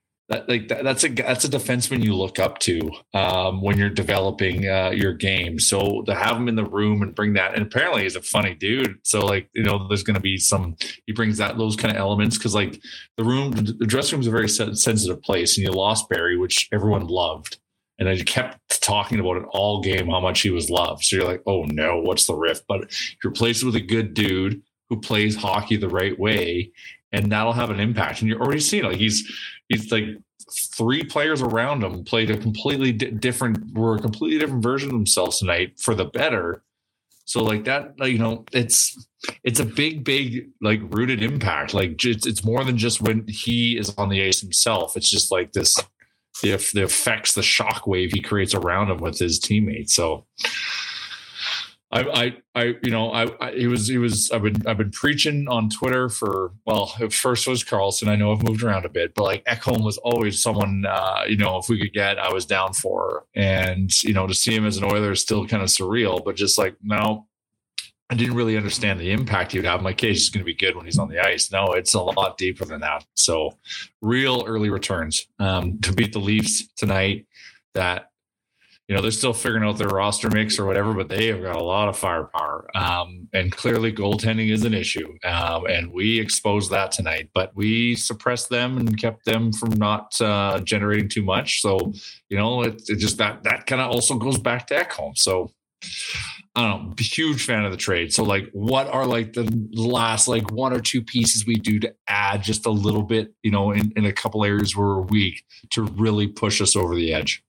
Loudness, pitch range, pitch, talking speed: -21 LUFS, 100-115 Hz, 110 Hz, 220 wpm